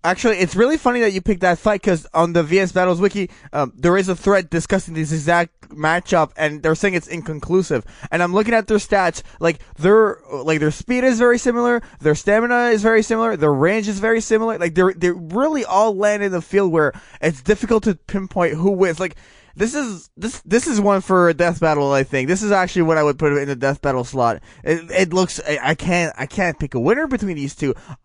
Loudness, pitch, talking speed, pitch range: -18 LUFS, 180 Hz, 230 wpm, 155-210 Hz